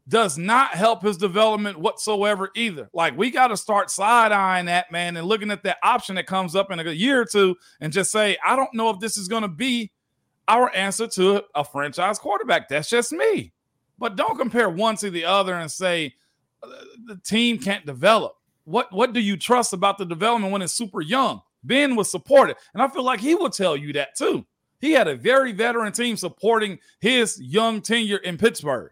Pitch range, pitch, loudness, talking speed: 185-230 Hz, 210 Hz, -21 LUFS, 205 wpm